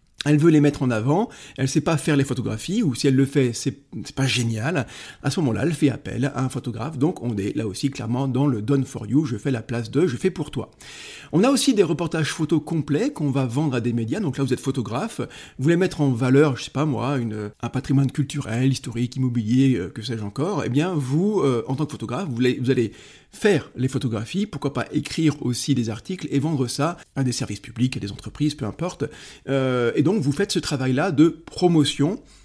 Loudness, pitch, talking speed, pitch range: -23 LUFS, 135 Hz, 235 wpm, 125-150 Hz